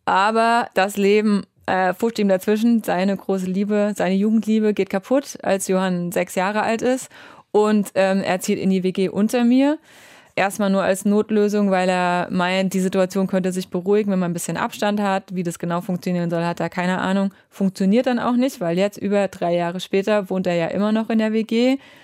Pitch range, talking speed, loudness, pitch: 185-215 Hz, 200 wpm, -20 LUFS, 195 Hz